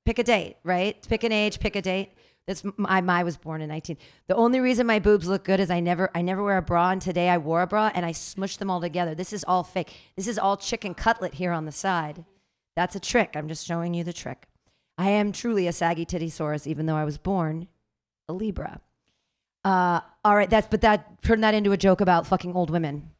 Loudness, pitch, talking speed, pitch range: -25 LUFS, 185 Hz, 245 wpm, 170-205 Hz